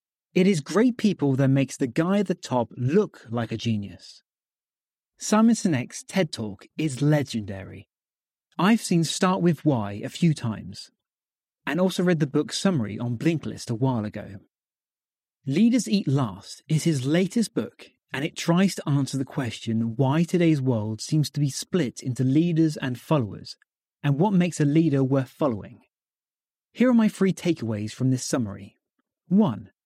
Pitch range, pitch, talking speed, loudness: 120-180 Hz, 150 Hz, 165 wpm, -24 LUFS